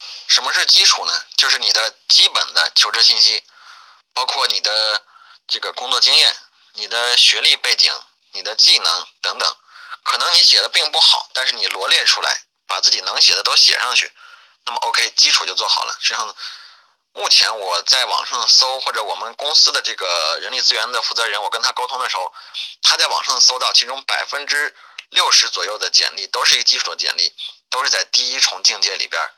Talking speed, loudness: 300 characters per minute, -14 LUFS